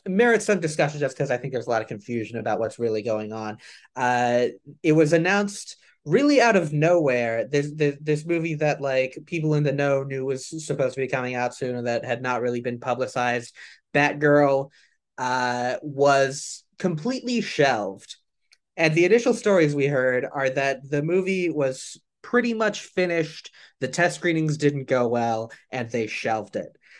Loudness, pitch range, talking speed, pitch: -23 LUFS, 125-165 Hz, 175 wpm, 140 Hz